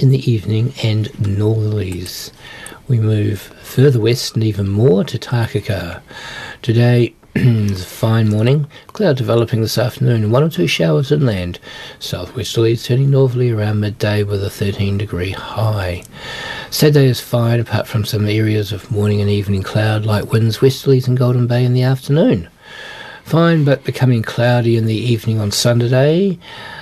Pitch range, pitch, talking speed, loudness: 105-130 Hz, 115 Hz, 155 wpm, -16 LUFS